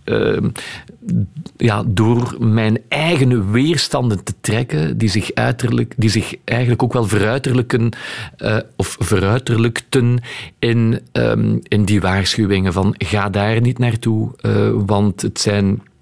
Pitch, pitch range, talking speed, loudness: 115 Hz, 105-125 Hz, 125 wpm, -17 LUFS